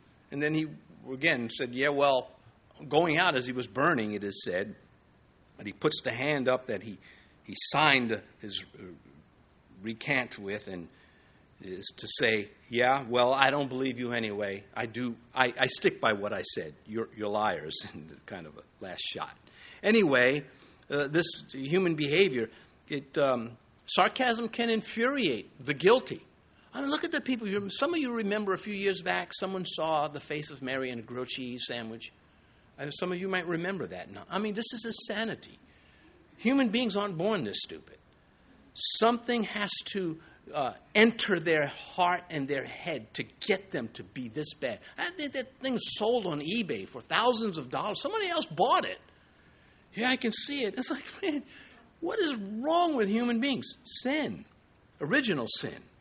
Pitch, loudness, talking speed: 170 Hz, -30 LUFS, 170 wpm